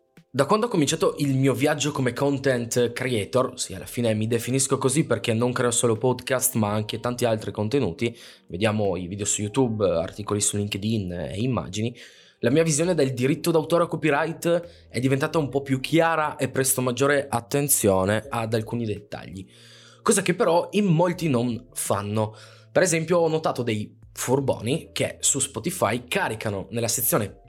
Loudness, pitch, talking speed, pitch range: -24 LUFS, 125 Hz, 165 wpm, 110-150 Hz